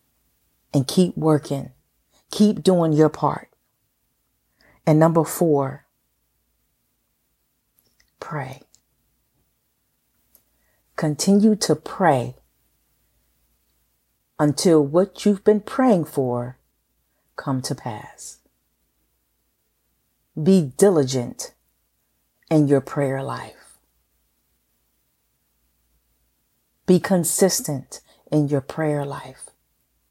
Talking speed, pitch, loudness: 70 wpm, 140 Hz, -20 LUFS